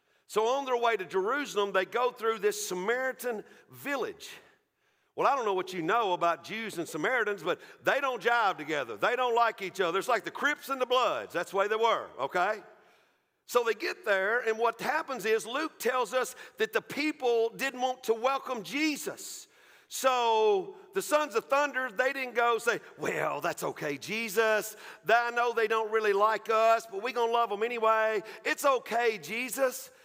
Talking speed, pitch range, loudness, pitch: 190 wpm, 220-270 Hz, -29 LUFS, 235 Hz